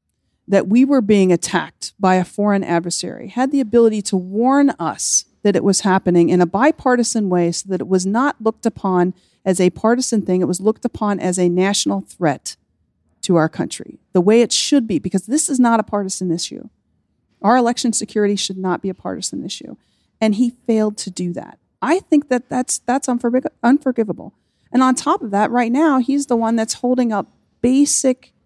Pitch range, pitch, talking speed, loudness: 185-250 Hz, 215 Hz, 195 wpm, -17 LUFS